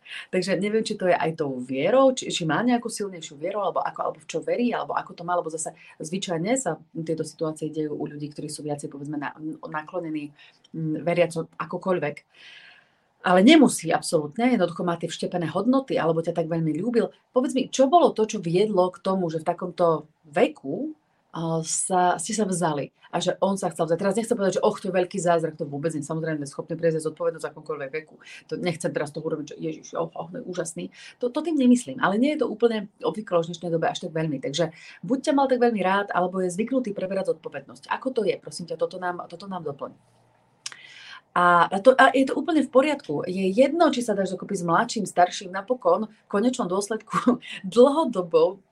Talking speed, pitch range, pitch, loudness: 210 wpm, 165-240 Hz, 180 Hz, -24 LUFS